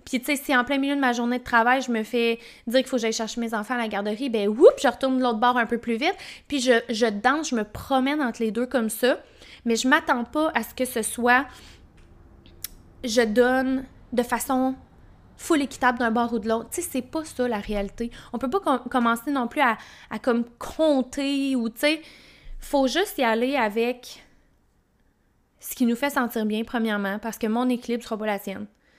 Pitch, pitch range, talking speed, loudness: 245 Hz, 230-270 Hz, 230 wpm, -24 LUFS